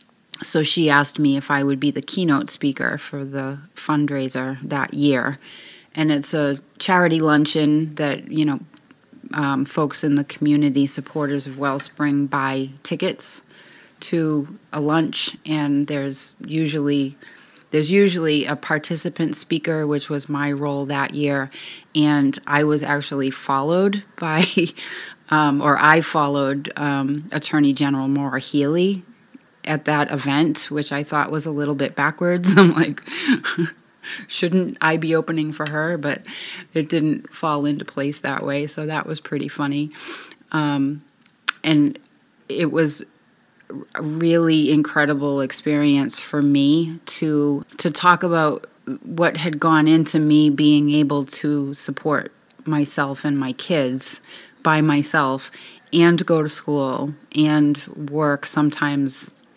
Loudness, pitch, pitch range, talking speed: -20 LUFS, 150 Hz, 145-160 Hz, 135 wpm